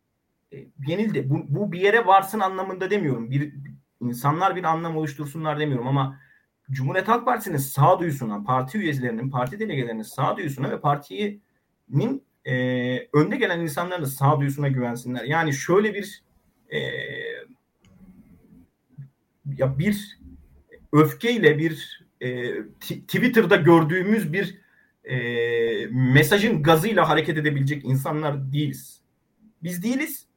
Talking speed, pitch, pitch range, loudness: 115 wpm, 150 Hz, 130-190 Hz, -23 LUFS